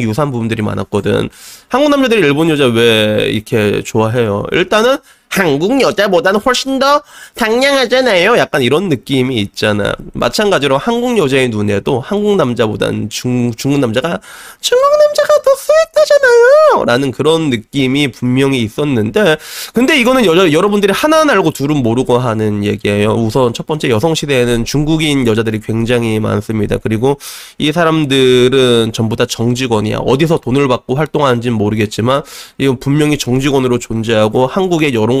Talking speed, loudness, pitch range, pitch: 365 characters per minute, -12 LUFS, 115-170 Hz, 135 Hz